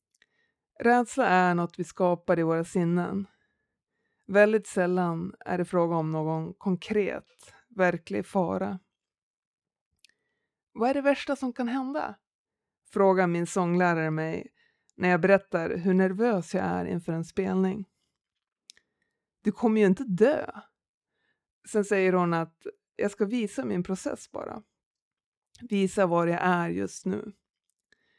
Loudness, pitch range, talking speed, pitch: -27 LUFS, 175-215 Hz, 130 wpm, 190 Hz